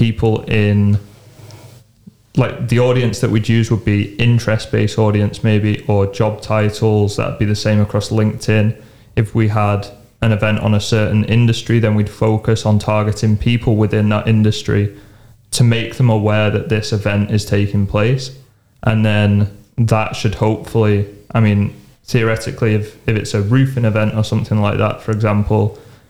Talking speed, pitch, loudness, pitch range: 165 wpm, 110 Hz, -16 LUFS, 105-115 Hz